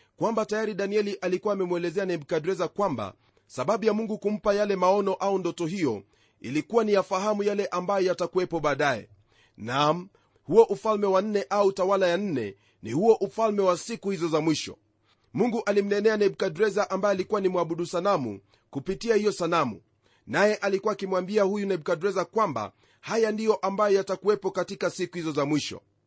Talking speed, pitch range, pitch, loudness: 150 wpm, 170-205 Hz, 190 Hz, -26 LUFS